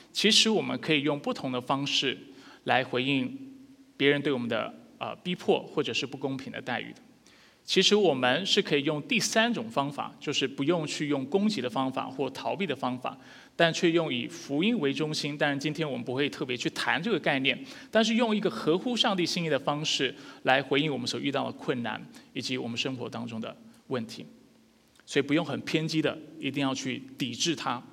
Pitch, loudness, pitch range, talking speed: 150 Hz, -28 LUFS, 135-180 Hz, 300 characters per minute